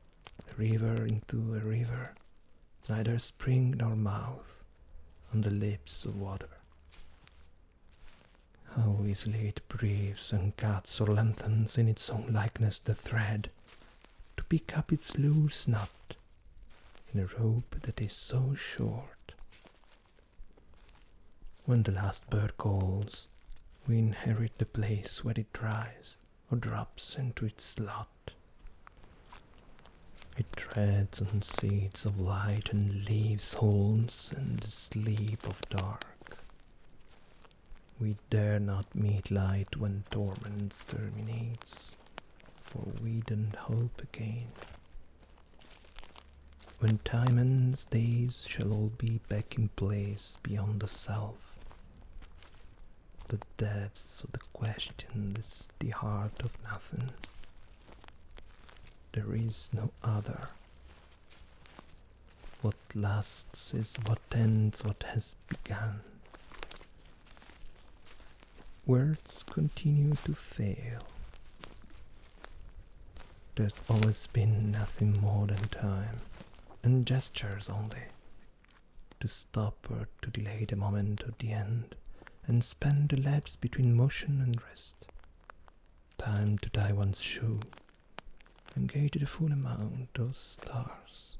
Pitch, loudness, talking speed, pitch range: 105 Hz, -34 LUFS, 105 wpm, 95-115 Hz